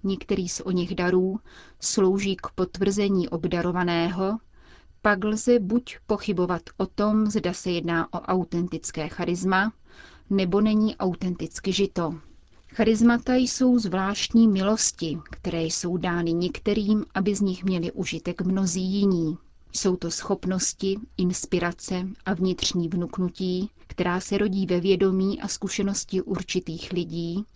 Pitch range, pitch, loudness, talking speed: 175-200 Hz, 190 Hz, -25 LUFS, 120 wpm